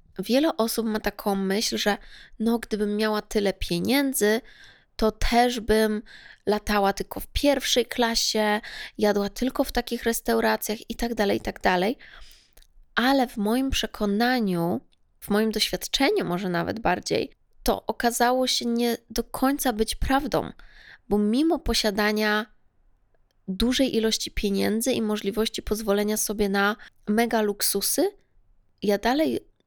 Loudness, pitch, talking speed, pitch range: -25 LUFS, 220 Hz, 125 wpm, 210-240 Hz